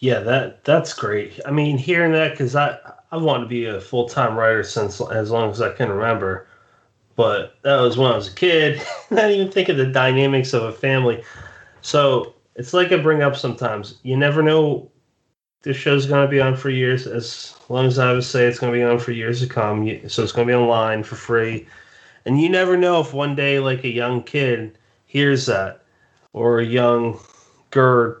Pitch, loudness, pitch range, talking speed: 125 Hz, -19 LUFS, 120-140 Hz, 210 wpm